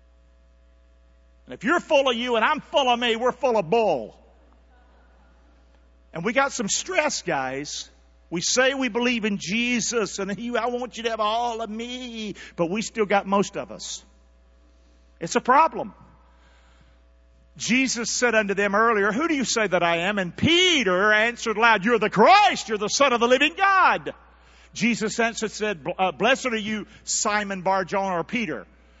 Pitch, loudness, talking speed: 210 Hz, -22 LUFS, 175 wpm